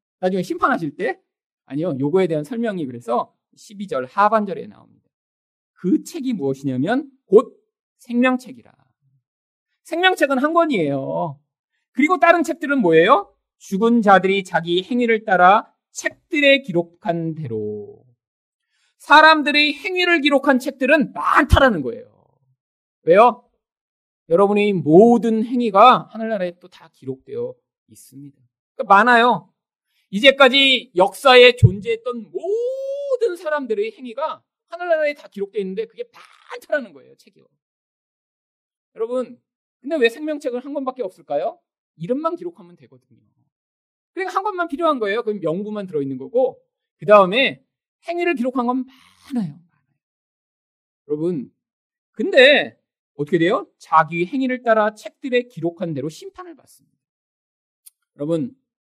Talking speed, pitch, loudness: 290 characters per minute, 240 Hz, -18 LUFS